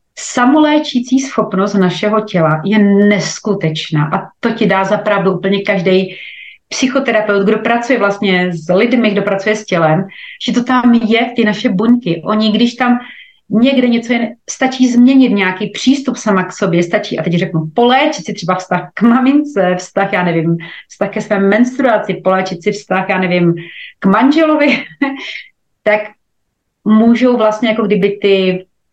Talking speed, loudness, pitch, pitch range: 150 wpm, -13 LUFS, 210 Hz, 190-240 Hz